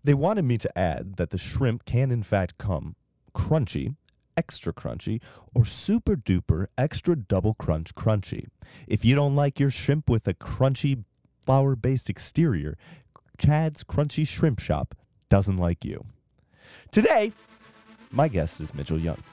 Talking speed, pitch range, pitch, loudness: 145 wpm, 95-140 Hz, 120 Hz, -26 LUFS